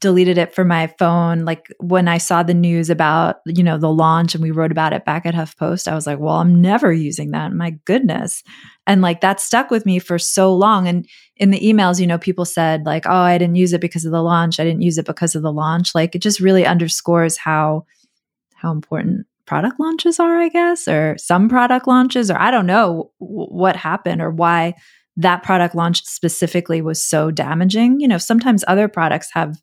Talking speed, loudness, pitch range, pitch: 220 wpm, -16 LUFS, 165-195 Hz, 175 Hz